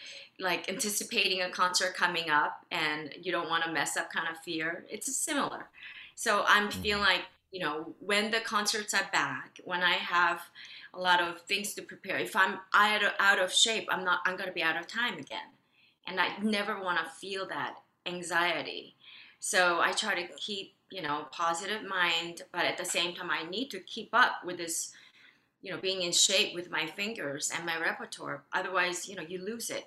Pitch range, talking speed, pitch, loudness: 170-200 Hz, 200 wpm, 180 Hz, -30 LUFS